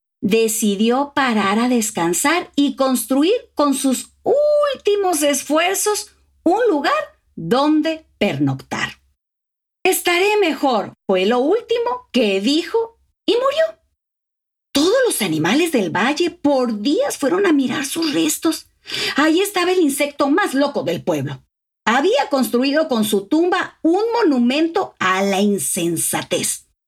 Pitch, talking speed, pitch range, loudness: 290 Hz, 120 wpm, 240-350 Hz, -18 LUFS